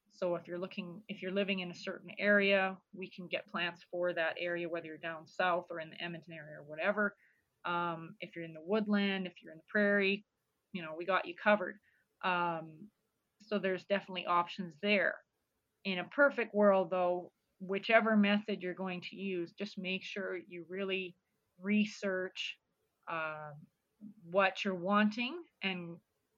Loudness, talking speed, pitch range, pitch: -35 LUFS, 170 wpm, 175-200 Hz, 185 Hz